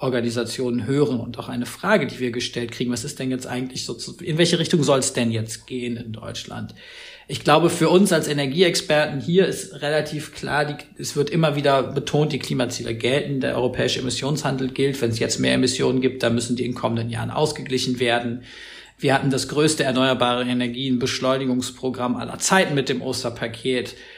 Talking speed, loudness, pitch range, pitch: 185 wpm, -22 LUFS, 120-145 Hz, 130 Hz